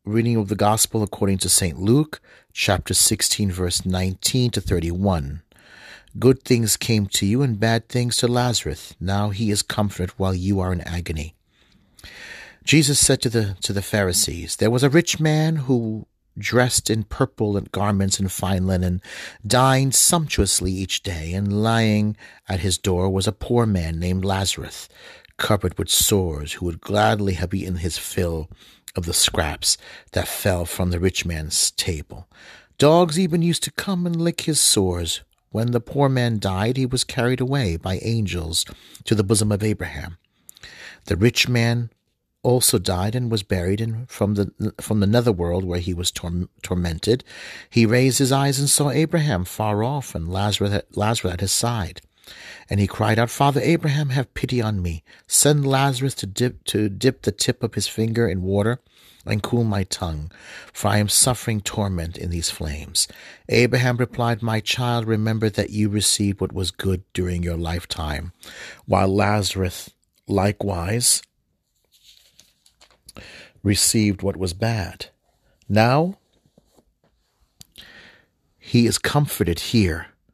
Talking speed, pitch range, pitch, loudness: 155 wpm, 95-120 Hz, 105 Hz, -21 LUFS